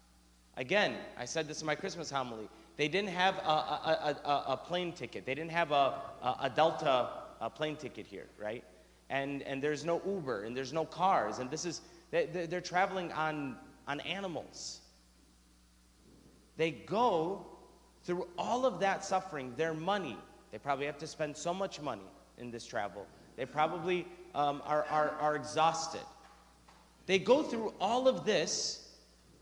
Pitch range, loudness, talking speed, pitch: 125-180 Hz, -35 LUFS, 165 wpm, 155 Hz